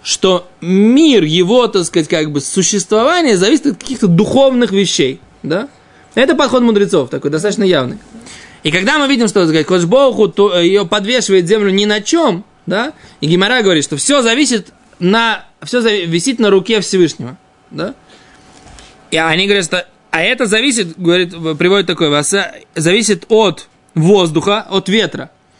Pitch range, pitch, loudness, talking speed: 180-230 Hz, 200 Hz, -12 LUFS, 145 wpm